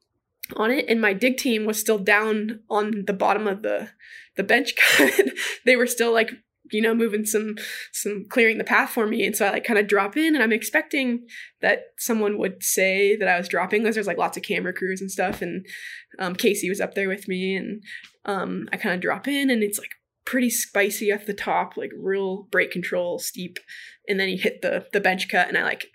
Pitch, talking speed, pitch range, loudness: 210 Hz, 225 wpm, 195-230 Hz, -22 LUFS